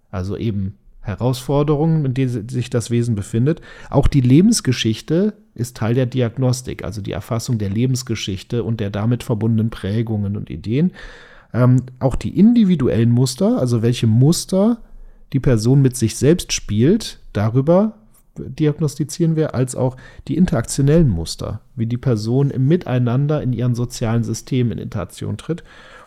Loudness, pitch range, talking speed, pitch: -18 LUFS, 115-145 Hz, 145 wpm, 125 Hz